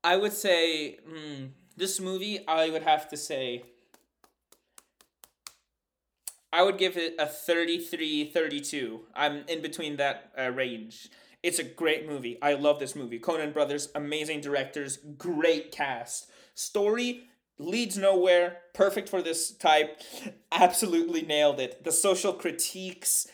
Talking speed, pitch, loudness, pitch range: 130 wpm, 165 Hz, -28 LUFS, 145-190 Hz